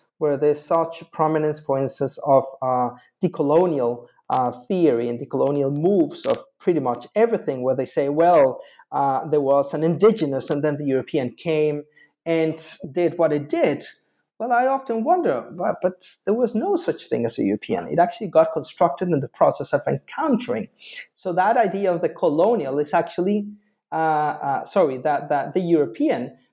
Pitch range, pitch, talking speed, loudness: 145-205 Hz, 160 Hz, 175 wpm, -22 LUFS